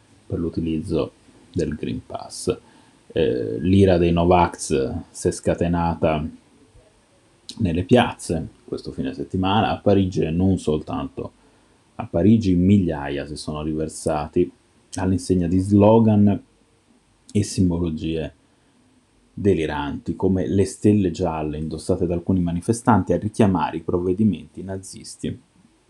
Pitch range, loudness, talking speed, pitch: 85-100 Hz, -21 LUFS, 110 wpm, 90 Hz